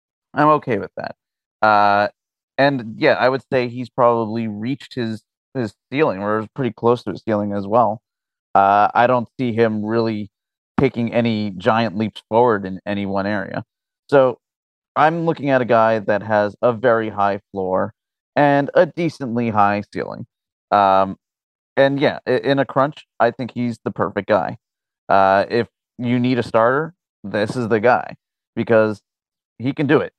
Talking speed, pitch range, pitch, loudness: 165 wpm, 105-130 Hz, 115 Hz, -19 LUFS